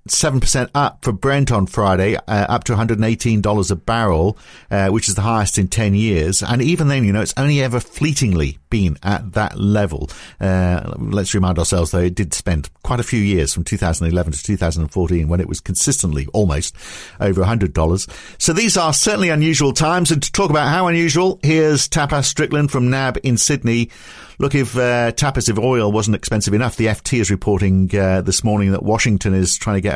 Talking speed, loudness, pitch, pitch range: 195 wpm, -17 LUFS, 105 Hz, 95-130 Hz